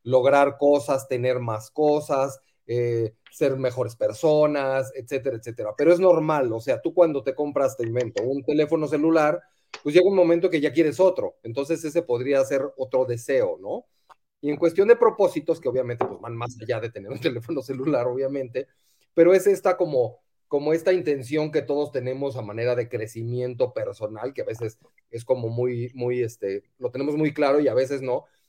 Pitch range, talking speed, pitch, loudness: 125-160 Hz, 185 wpm, 140 Hz, -24 LUFS